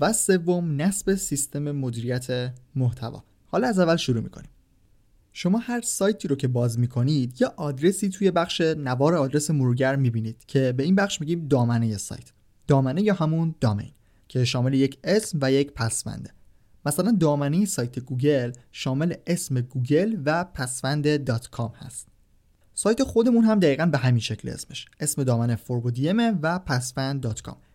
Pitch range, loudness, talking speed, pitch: 120-170 Hz, -24 LUFS, 150 wpm, 140 Hz